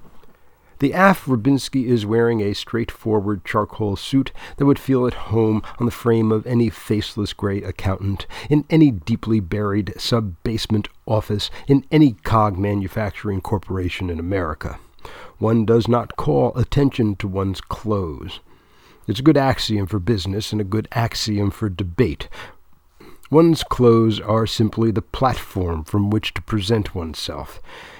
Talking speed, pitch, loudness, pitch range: 140 wpm, 110 Hz, -20 LUFS, 100-120 Hz